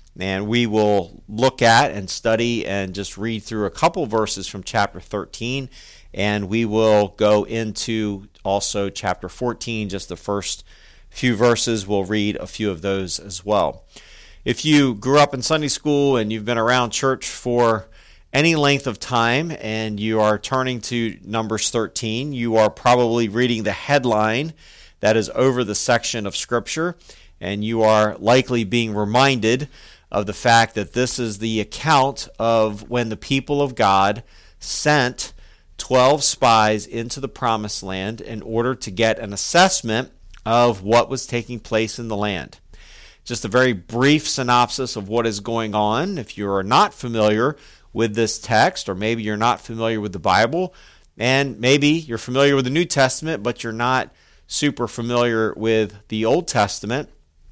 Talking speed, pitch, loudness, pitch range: 165 wpm, 115 Hz, -20 LUFS, 105-125 Hz